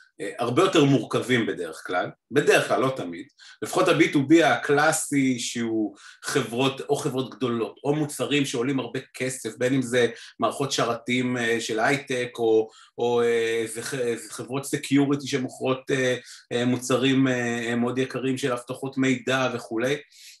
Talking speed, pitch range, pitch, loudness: 120 wpm, 120-135 Hz, 130 Hz, -24 LUFS